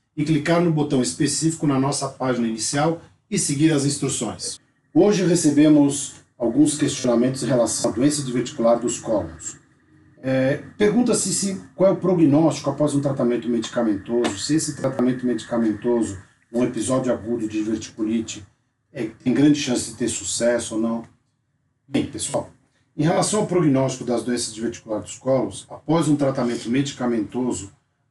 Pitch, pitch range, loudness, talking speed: 130 Hz, 120-150 Hz, -21 LUFS, 150 wpm